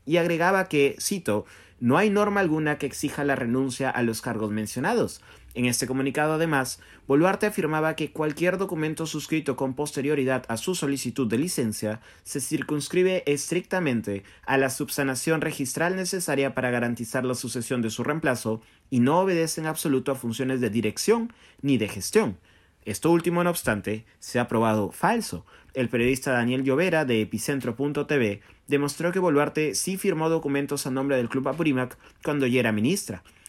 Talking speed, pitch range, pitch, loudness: 160 wpm, 120-160 Hz, 135 Hz, -25 LUFS